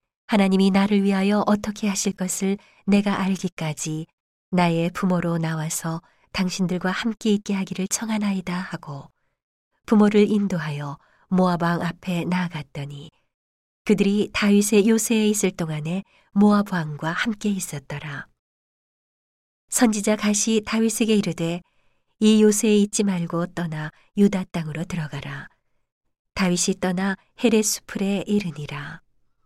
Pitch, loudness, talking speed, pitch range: 190 Hz, -22 LUFS, 275 characters per minute, 165-205 Hz